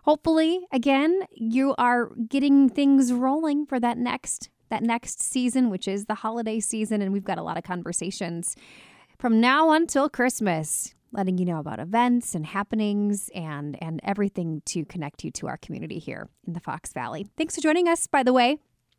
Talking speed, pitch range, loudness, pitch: 180 wpm, 195-275 Hz, -25 LUFS, 230 Hz